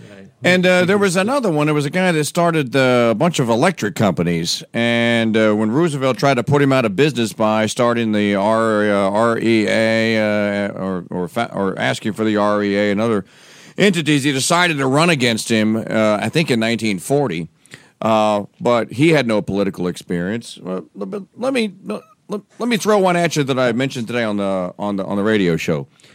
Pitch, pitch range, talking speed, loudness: 115 Hz, 105-150 Hz, 200 wpm, -17 LUFS